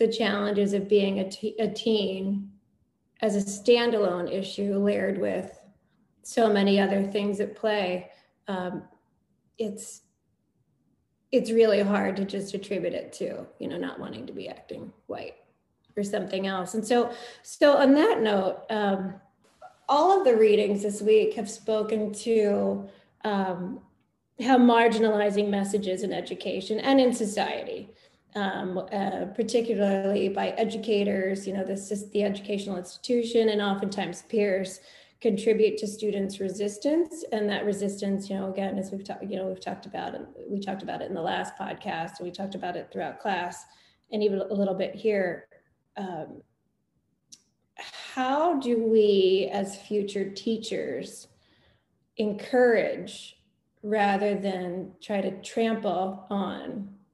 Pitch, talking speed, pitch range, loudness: 205 Hz, 140 wpm, 195-220 Hz, -27 LUFS